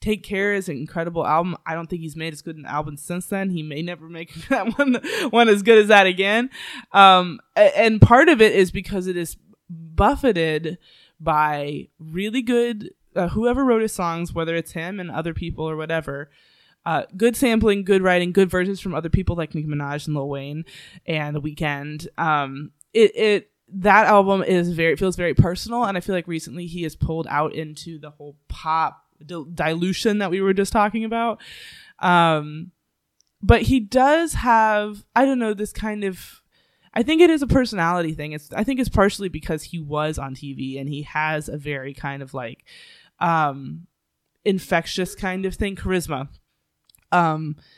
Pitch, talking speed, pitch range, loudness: 175 Hz, 185 wpm, 155-210 Hz, -20 LUFS